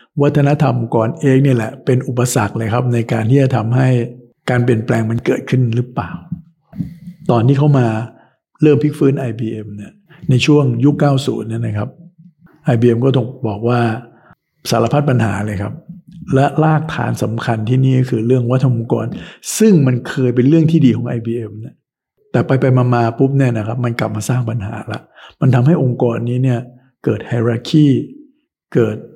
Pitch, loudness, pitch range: 125 Hz, -15 LUFS, 115-145 Hz